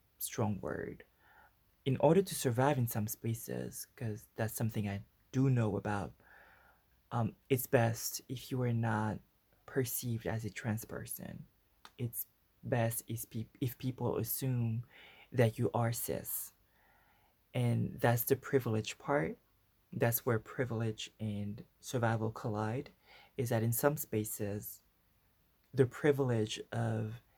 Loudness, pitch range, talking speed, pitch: -36 LUFS, 110-130 Hz, 125 wpm, 115 Hz